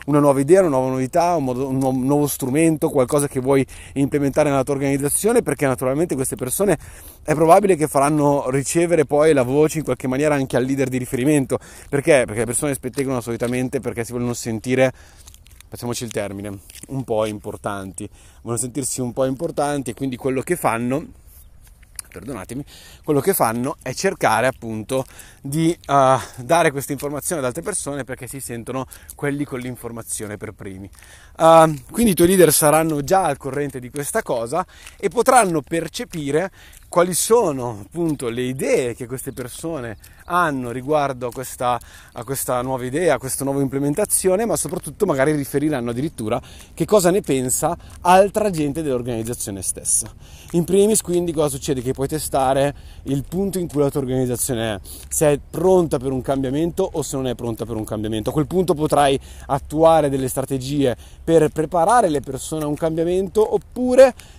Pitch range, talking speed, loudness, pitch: 125-160 Hz, 165 wpm, -20 LUFS, 140 Hz